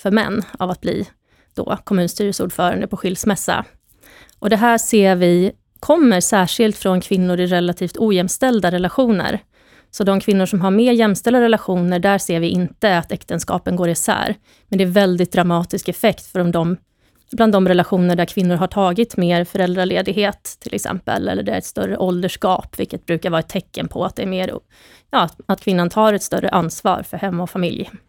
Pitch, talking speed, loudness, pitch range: 190 Hz, 180 wpm, -18 LUFS, 180-210 Hz